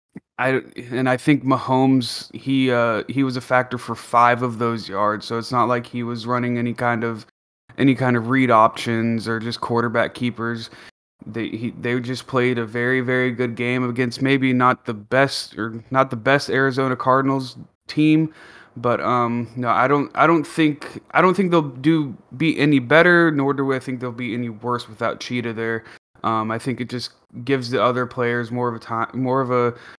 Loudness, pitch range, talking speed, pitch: -20 LUFS, 120-135 Hz, 200 wpm, 125 Hz